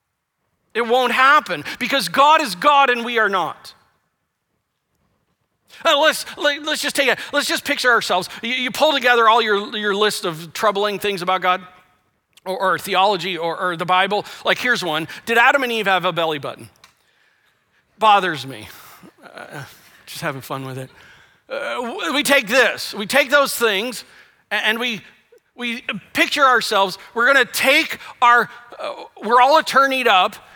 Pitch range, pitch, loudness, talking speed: 185-270 Hz, 225 Hz, -17 LUFS, 165 wpm